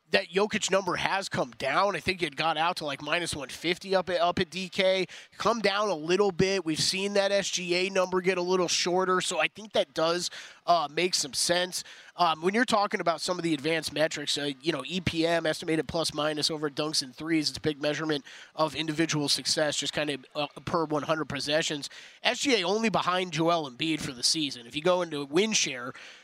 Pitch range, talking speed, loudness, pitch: 155-185 Hz, 215 wpm, -28 LUFS, 170 Hz